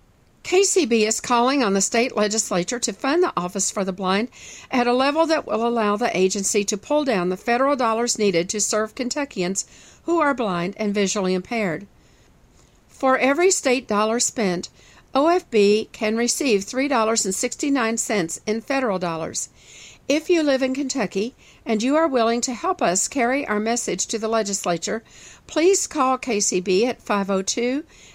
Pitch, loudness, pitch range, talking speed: 230 Hz, -21 LUFS, 205-265 Hz, 160 wpm